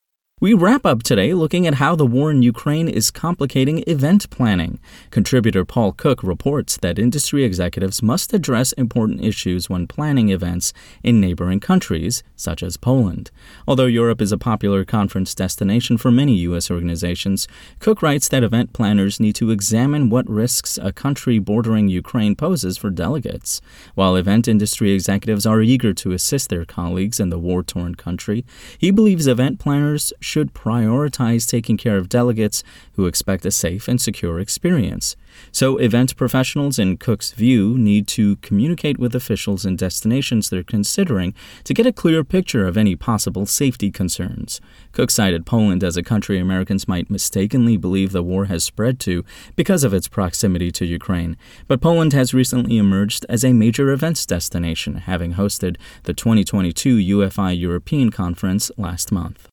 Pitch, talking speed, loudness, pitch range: 105 Hz, 160 wpm, -18 LUFS, 95-125 Hz